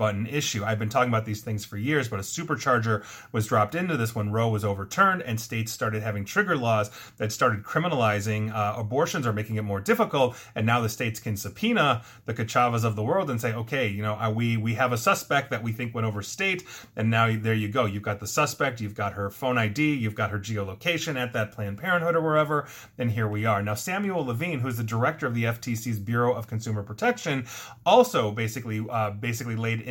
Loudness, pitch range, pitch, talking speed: -26 LUFS, 110-130 Hz, 115 Hz, 225 wpm